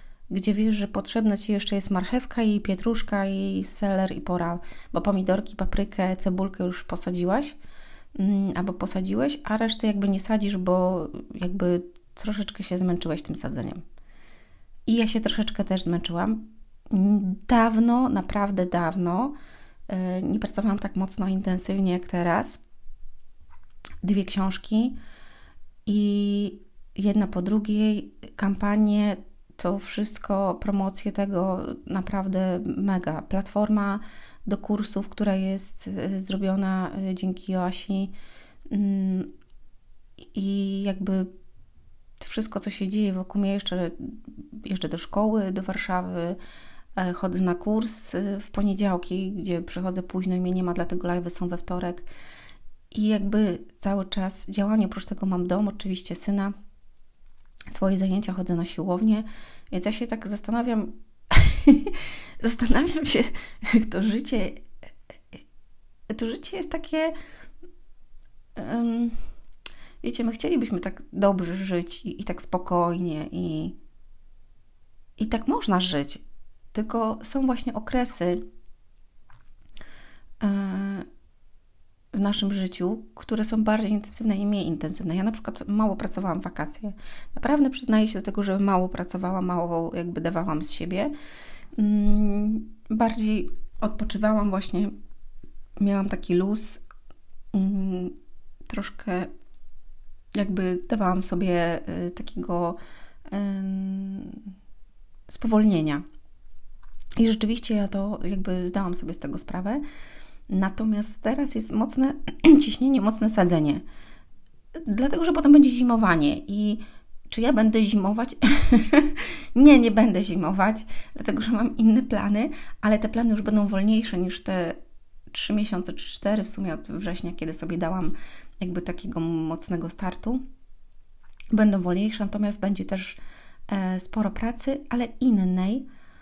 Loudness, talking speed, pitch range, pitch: -25 LUFS, 115 wpm, 180-220 Hz, 200 Hz